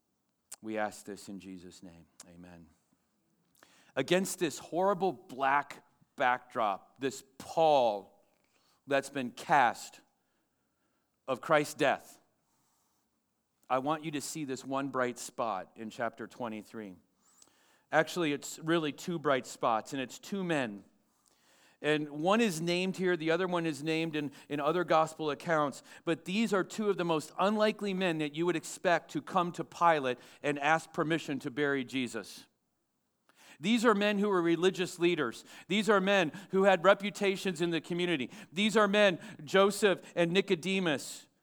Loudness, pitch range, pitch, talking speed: -31 LUFS, 135-185 Hz, 160 Hz, 150 wpm